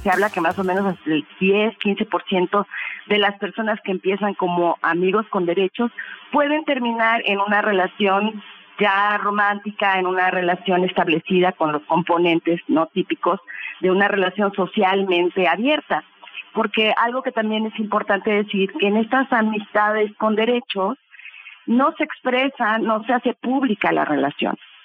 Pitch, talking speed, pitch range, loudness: 200 Hz, 145 wpm, 185-220 Hz, -20 LUFS